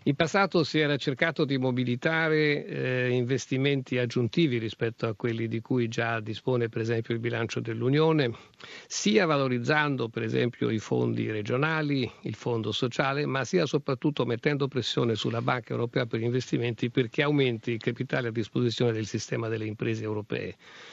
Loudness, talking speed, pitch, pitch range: -28 LUFS, 155 wpm, 125 Hz, 115-145 Hz